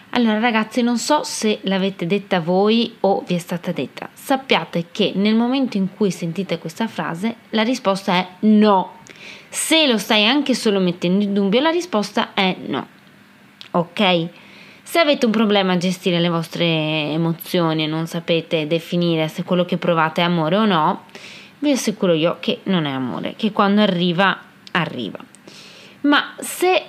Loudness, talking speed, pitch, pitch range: -19 LUFS, 165 wpm, 195 Hz, 175-220 Hz